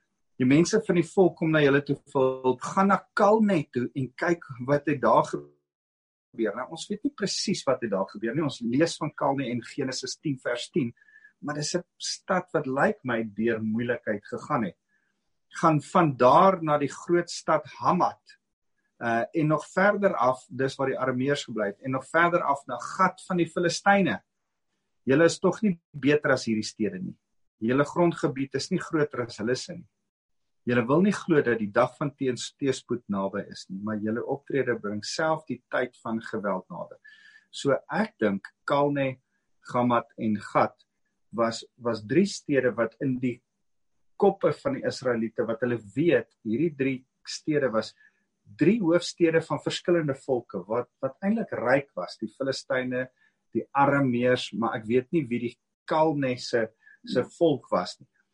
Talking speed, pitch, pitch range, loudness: 175 wpm, 135 Hz, 120-170 Hz, -26 LUFS